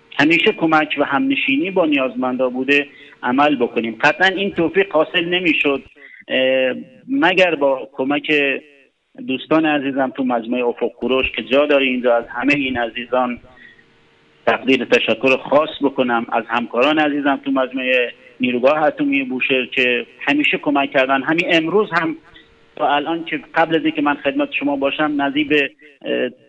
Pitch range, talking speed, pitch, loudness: 130-155 Hz, 140 wpm, 140 Hz, -17 LUFS